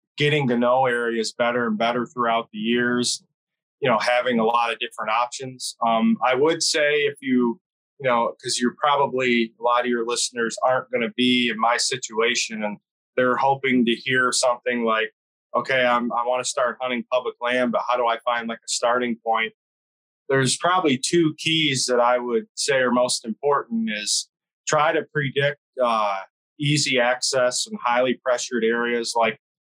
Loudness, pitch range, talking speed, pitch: -22 LUFS, 115-130 Hz, 180 wpm, 125 Hz